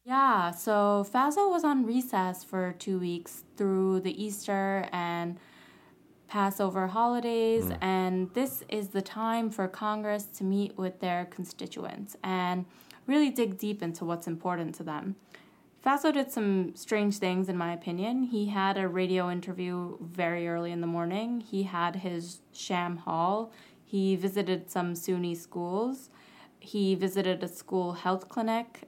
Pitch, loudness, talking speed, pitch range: 190 Hz, -31 LUFS, 145 wpm, 180-215 Hz